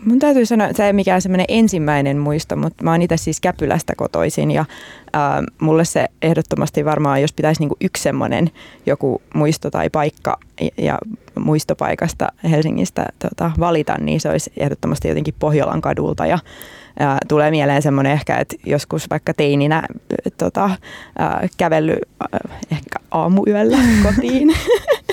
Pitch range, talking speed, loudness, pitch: 150-200 Hz, 145 wpm, -17 LUFS, 160 Hz